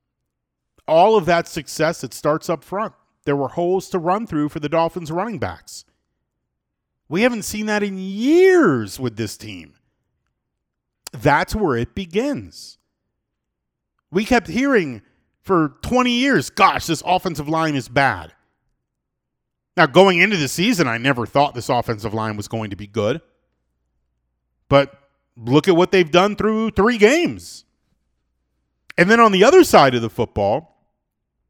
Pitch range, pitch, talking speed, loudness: 115-190 Hz, 150 Hz, 150 wpm, -18 LUFS